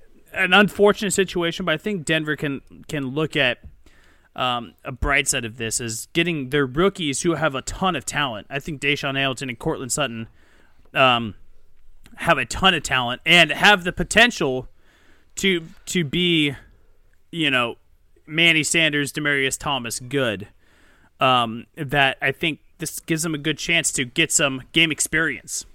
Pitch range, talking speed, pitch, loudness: 125-165 Hz, 160 wpm, 145 Hz, -20 LUFS